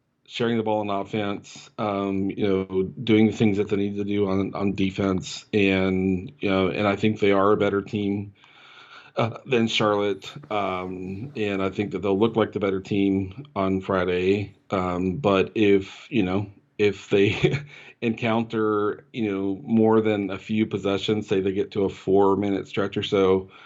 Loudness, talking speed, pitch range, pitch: -24 LUFS, 180 wpm, 95-105 Hz, 100 Hz